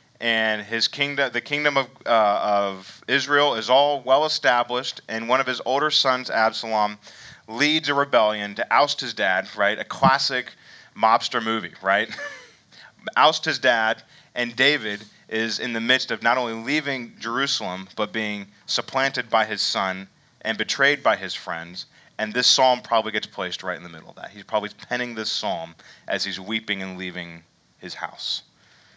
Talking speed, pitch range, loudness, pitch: 170 wpm, 105-130 Hz, -22 LUFS, 115 Hz